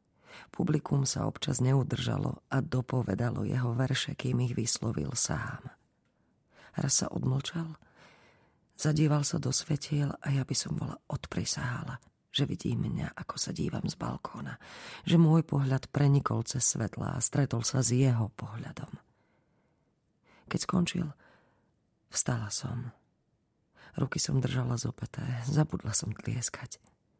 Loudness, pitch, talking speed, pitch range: -31 LUFS, 135 Hz, 125 wpm, 120-145 Hz